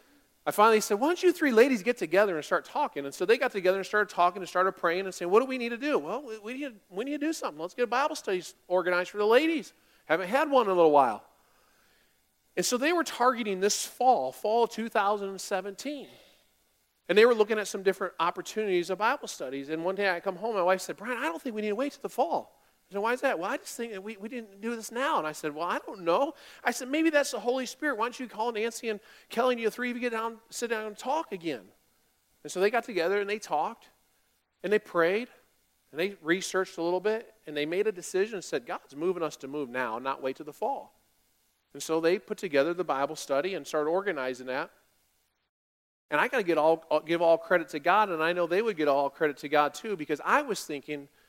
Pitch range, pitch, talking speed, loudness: 165-240 Hz, 200 Hz, 255 wpm, -29 LUFS